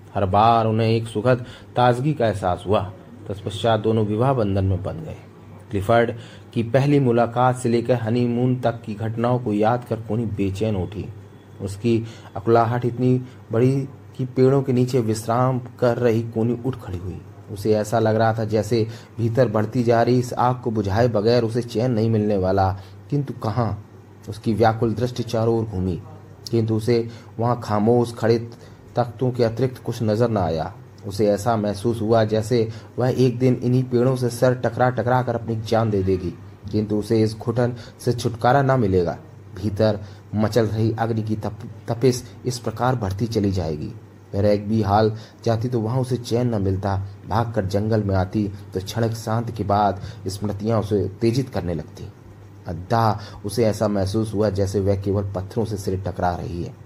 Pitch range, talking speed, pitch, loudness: 105-120 Hz, 175 wpm, 110 Hz, -22 LUFS